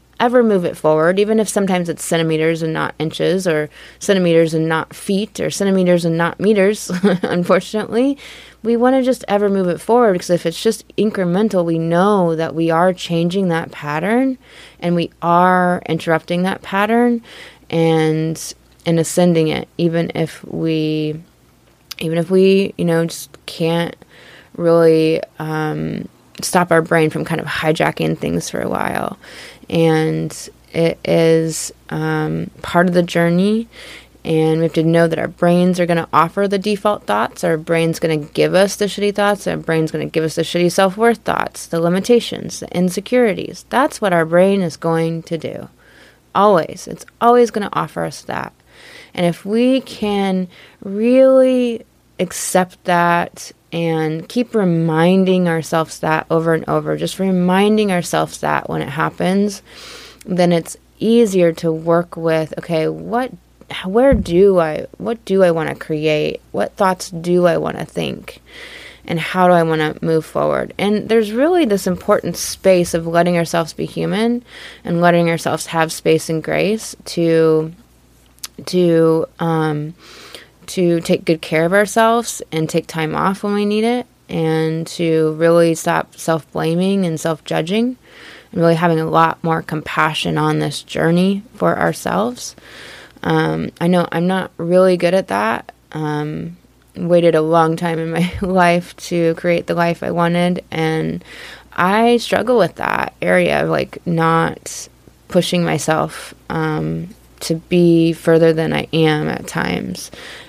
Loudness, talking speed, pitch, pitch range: -16 LUFS, 160 wpm, 170 Hz, 160-195 Hz